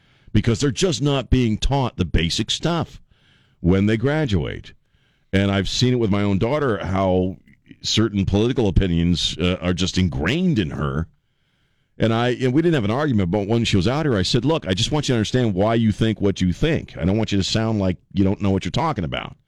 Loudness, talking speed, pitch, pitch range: -20 LUFS, 225 wpm, 110 Hz, 95-130 Hz